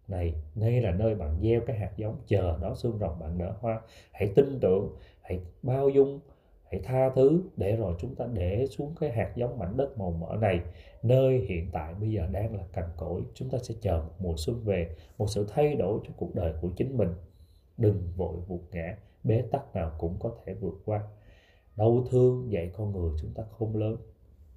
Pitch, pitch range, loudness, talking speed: 100 Hz, 85-115 Hz, -30 LUFS, 215 wpm